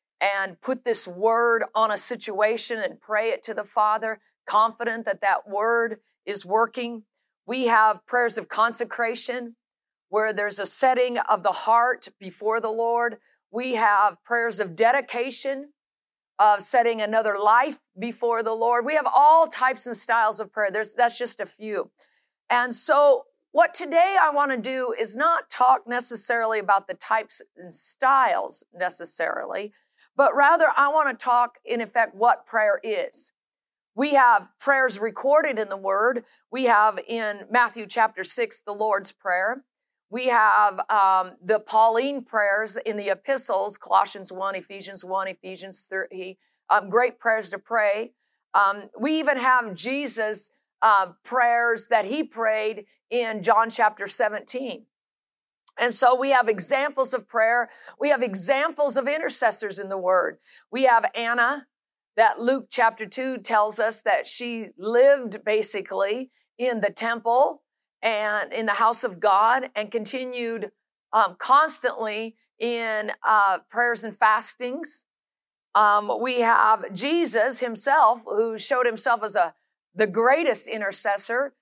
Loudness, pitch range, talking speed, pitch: -22 LUFS, 210-250 Hz, 145 wpm, 230 Hz